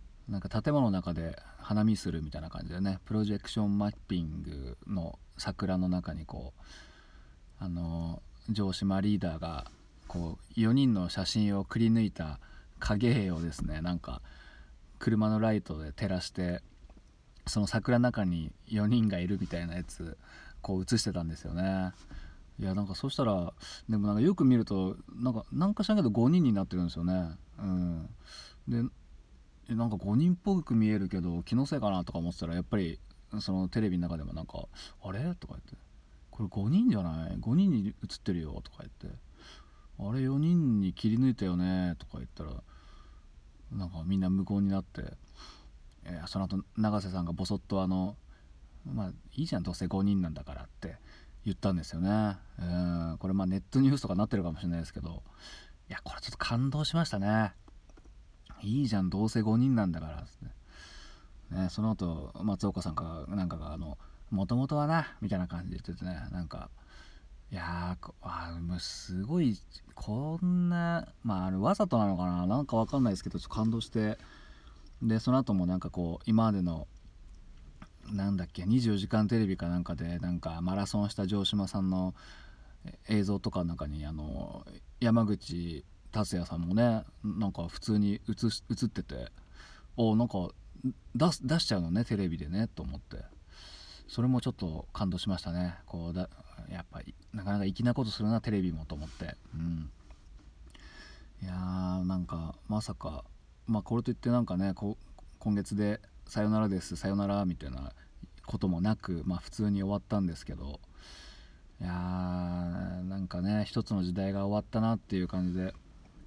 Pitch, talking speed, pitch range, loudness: 95 Hz, 330 characters per minute, 85-105 Hz, -32 LUFS